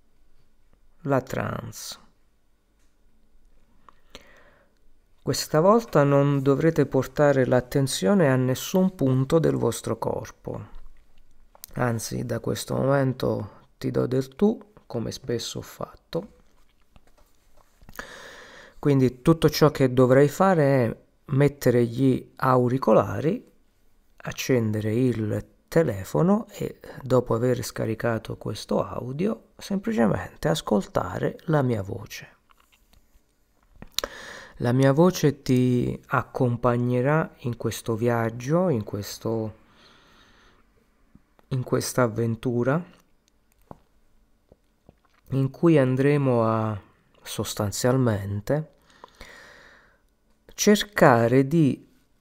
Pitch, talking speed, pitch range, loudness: 130 Hz, 80 wpm, 115-145 Hz, -24 LUFS